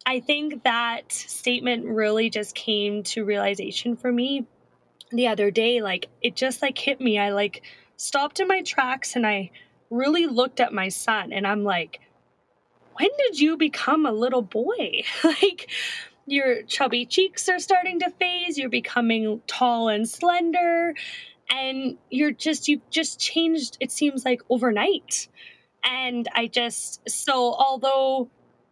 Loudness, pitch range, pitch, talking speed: -23 LUFS, 230-315 Hz, 255 Hz, 150 wpm